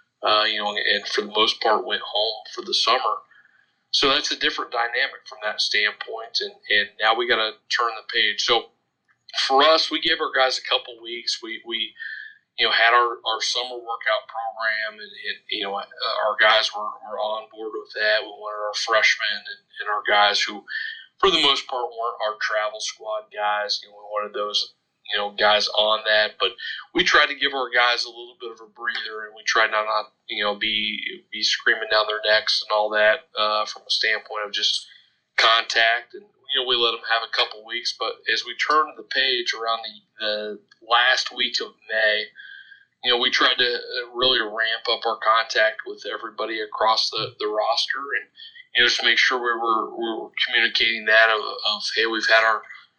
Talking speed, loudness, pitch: 210 wpm, -21 LUFS, 115 Hz